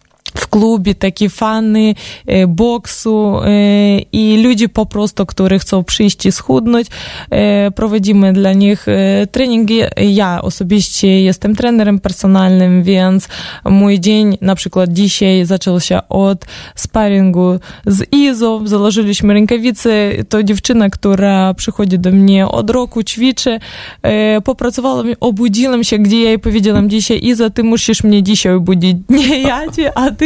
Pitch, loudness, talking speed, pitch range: 210 Hz, -11 LUFS, 140 wpm, 195-225 Hz